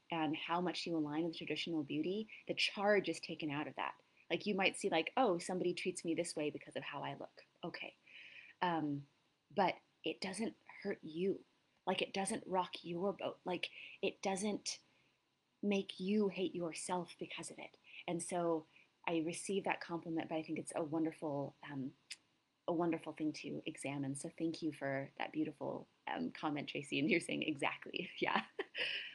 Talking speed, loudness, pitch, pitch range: 175 wpm, -40 LUFS, 165 Hz, 155-185 Hz